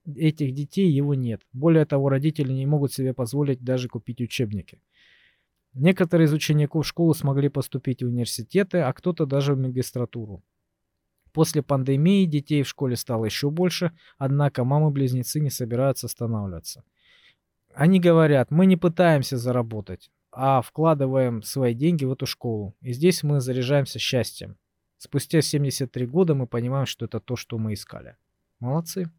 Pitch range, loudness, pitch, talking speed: 120-155 Hz, -23 LUFS, 135 Hz, 145 wpm